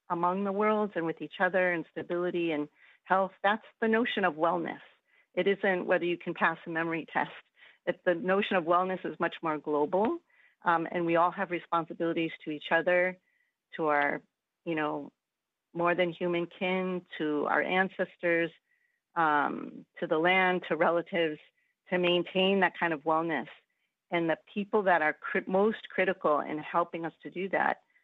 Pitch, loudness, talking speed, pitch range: 175 Hz, -30 LUFS, 170 wpm, 165-190 Hz